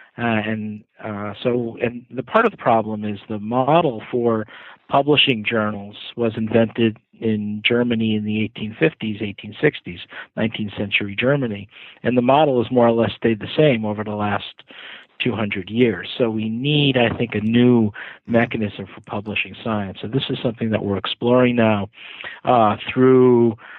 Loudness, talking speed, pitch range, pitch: -20 LUFS, 160 wpm, 105-125 Hz, 115 Hz